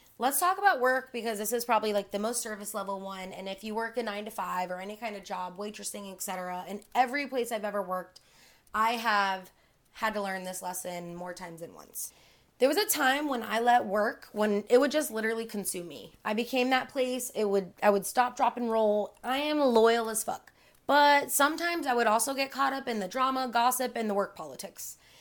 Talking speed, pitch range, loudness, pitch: 225 wpm, 200-255 Hz, -29 LUFS, 220 Hz